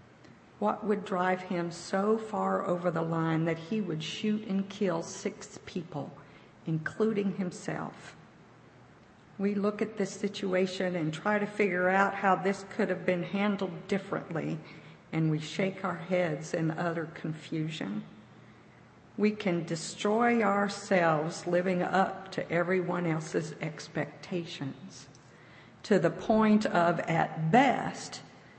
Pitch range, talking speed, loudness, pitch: 165-200 Hz, 125 wpm, -31 LUFS, 185 Hz